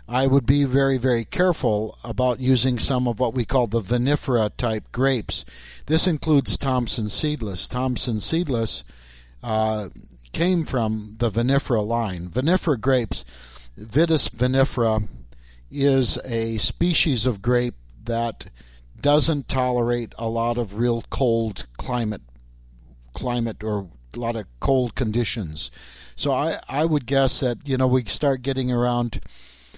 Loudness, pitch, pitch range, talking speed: -21 LUFS, 120 Hz, 105-130 Hz, 135 wpm